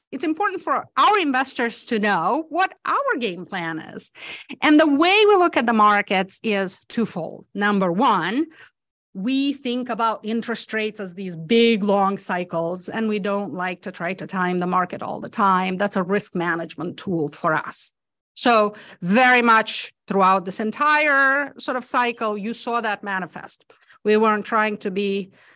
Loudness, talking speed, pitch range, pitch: -21 LUFS, 170 wpm, 190-250 Hz, 215 Hz